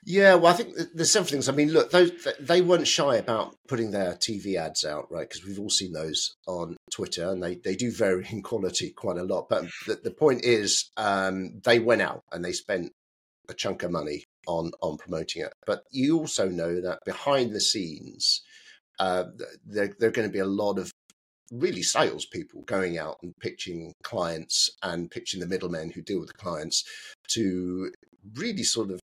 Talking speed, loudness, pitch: 195 wpm, -26 LUFS, 105 Hz